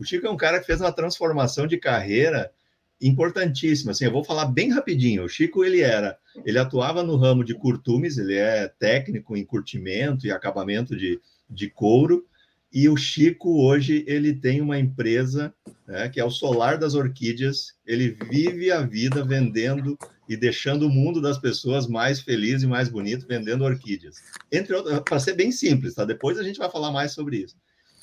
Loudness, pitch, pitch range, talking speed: -23 LUFS, 140 Hz, 120-155 Hz, 185 wpm